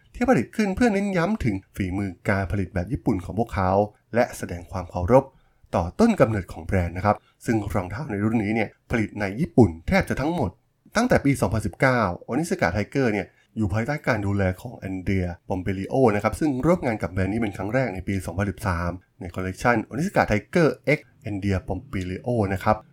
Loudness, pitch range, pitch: -24 LUFS, 95-125 Hz, 105 Hz